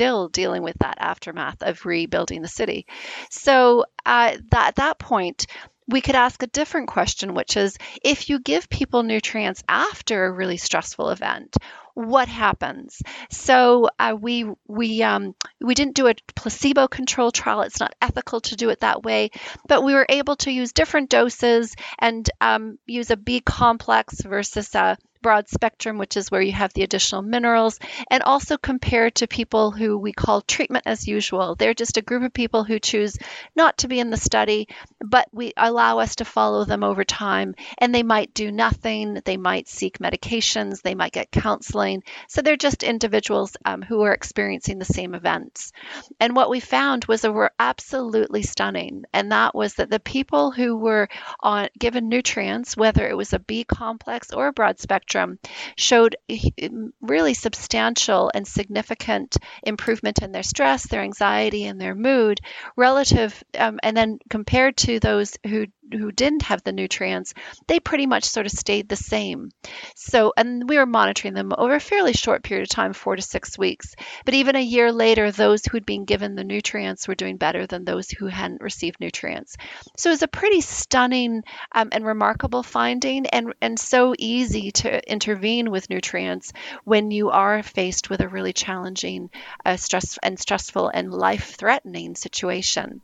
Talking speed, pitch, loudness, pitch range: 175 wpm, 225 Hz, -21 LUFS, 195-250 Hz